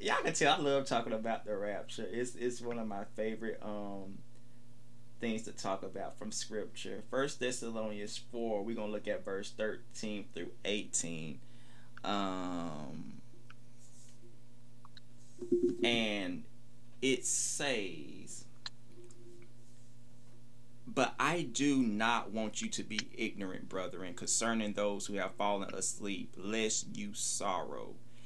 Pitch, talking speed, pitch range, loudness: 120 Hz, 120 wpm, 105-120 Hz, -36 LUFS